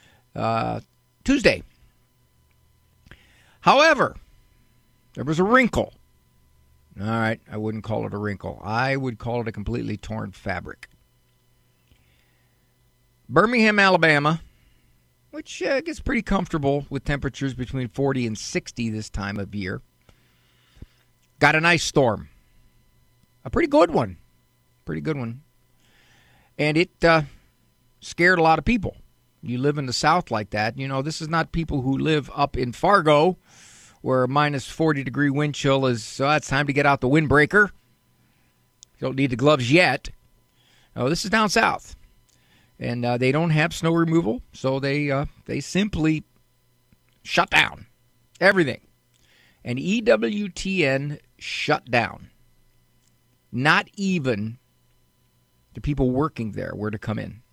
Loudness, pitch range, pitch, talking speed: -22 LUFS, 110-155 Hz, 130 Hz, 140 wpm